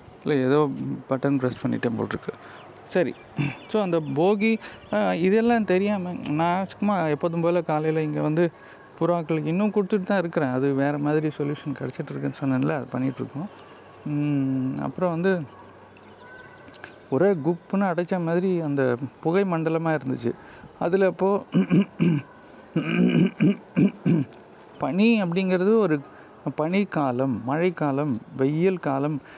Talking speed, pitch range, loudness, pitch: 105 wpm, 140-190 Hz, -24 LUFS, 160 Hz